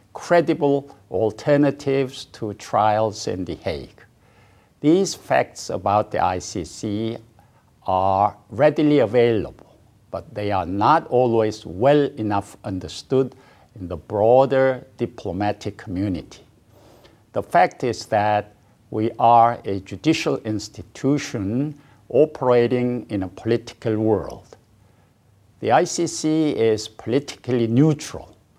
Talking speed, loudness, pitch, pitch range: 100 wpm, -21 LUFS, 115 Hz, 105-130 Hz